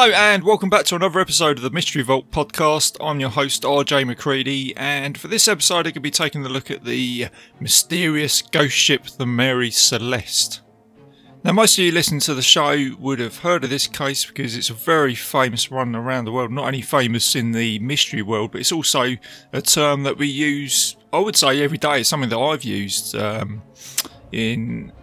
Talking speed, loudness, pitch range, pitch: 205 wpm, -18 LUFS, 120-155 Hz, 135 Hz